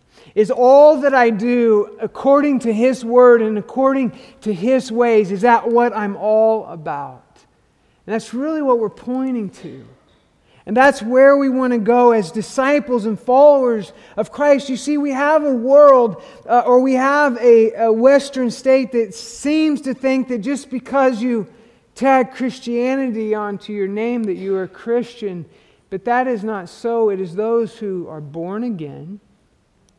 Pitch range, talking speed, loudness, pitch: 215-260 Hz, 170 wpm, -16 LUFS, 240 Hz